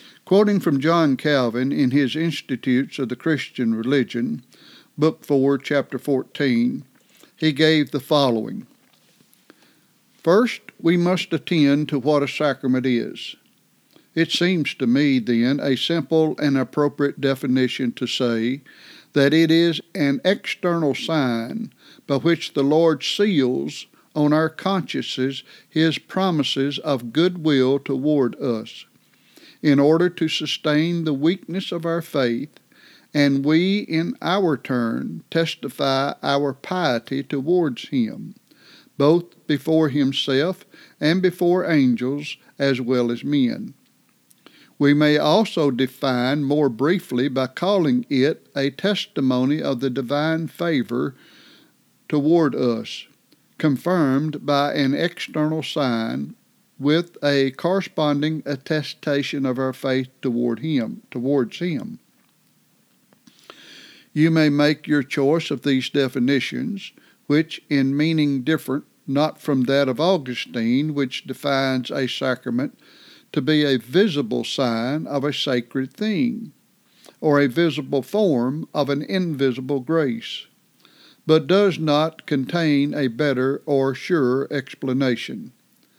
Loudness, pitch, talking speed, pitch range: -21 LUFS, 145 Hz, 120 wpm, 135-165 Hz